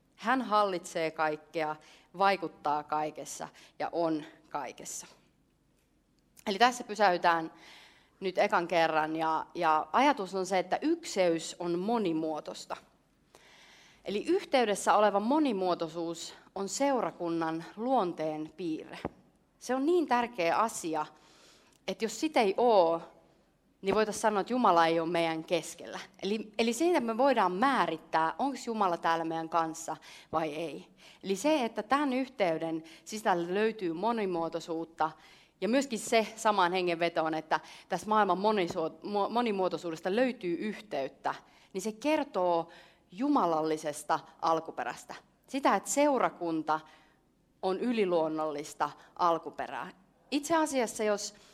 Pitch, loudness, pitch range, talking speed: 180 Hz, -31 LUFS, 165-225 Hz, 115 wpm